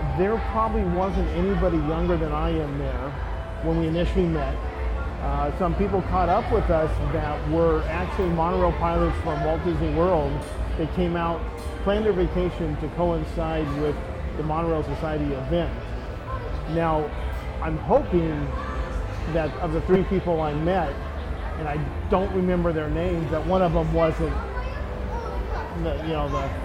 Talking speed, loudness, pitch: 150 wpm, -25 LUFS, 155 Hz